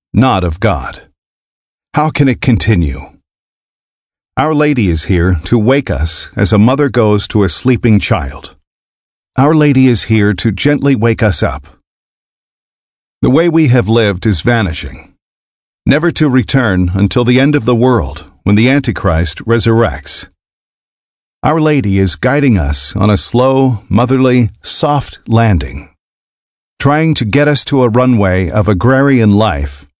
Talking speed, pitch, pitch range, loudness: 145 wpm, 115 Hz, 95-130 Hz, -11 LUFS